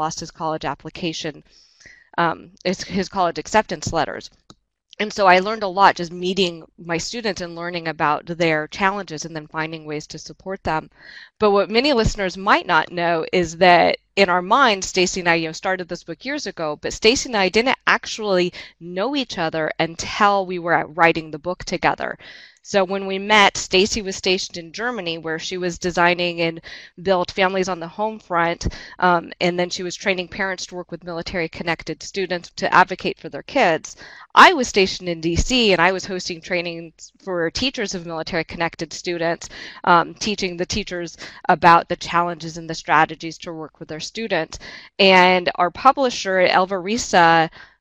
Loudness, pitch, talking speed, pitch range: -19 LUFS, 180 Hz, 180 wpm, 165-195 Hz